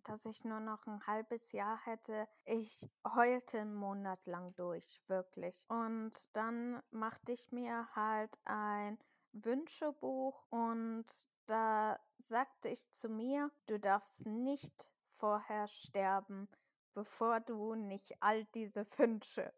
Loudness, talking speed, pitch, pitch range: -41 LUFS, 125 wpm, 220 Hz, 210-235 Hz